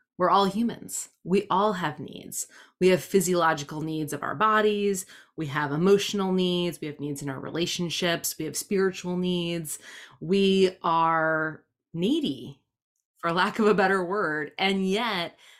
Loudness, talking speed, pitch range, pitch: -26 LUFS, 150 wpm, 155-195 Hz, 180 Hz